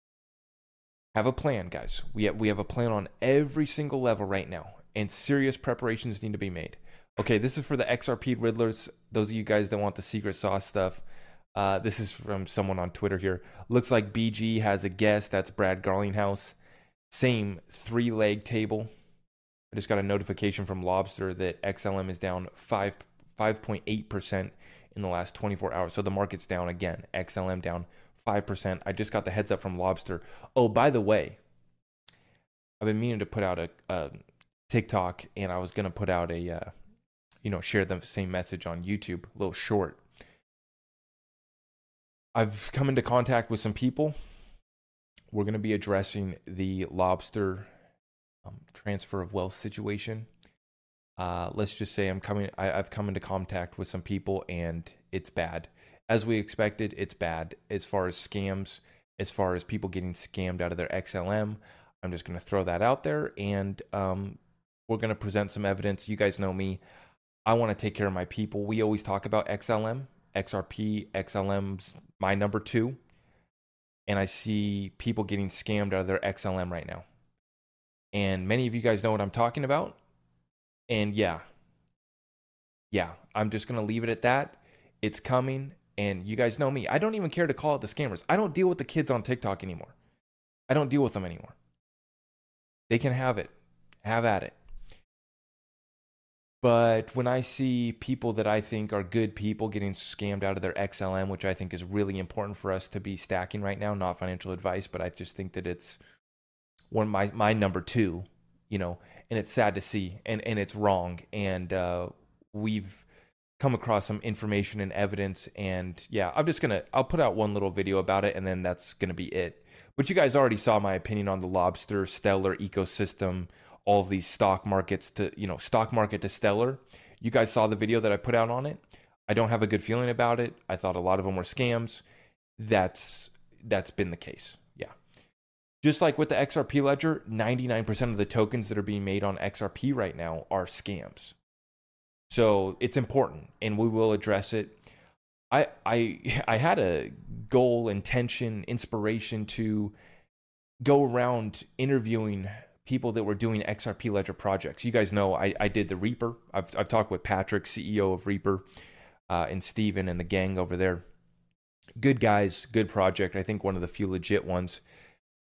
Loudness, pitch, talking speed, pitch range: -30 LUFS, 100 Hz, 185 wpm, 95-110 Hz